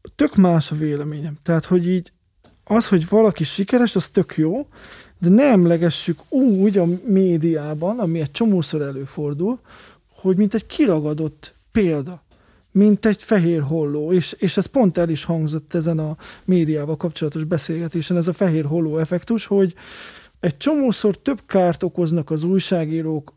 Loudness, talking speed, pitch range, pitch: -19 LUFS, 150 wpm, 155-200 Hz, 175 Hz